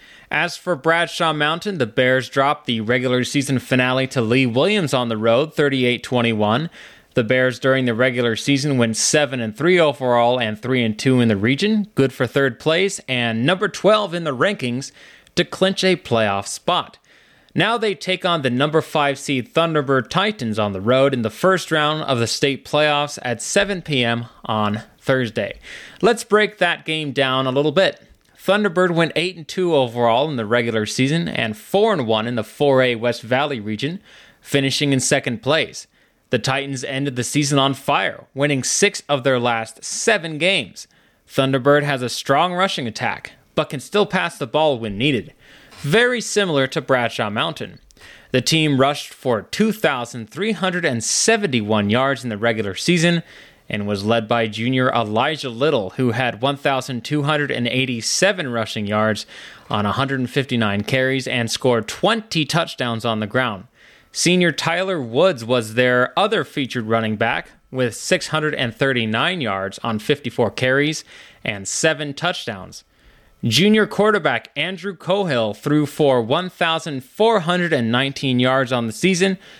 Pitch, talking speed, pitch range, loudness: 135 Hz, 150 wpm, 120-165 Hz, -19 LUFS